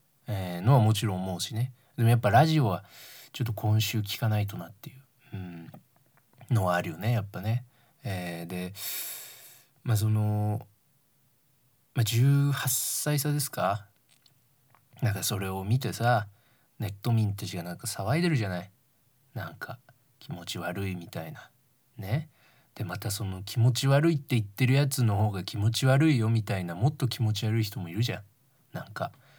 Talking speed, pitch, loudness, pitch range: 305 characters per minute, 115 Hz, -28 LUFS, 105-130 Hz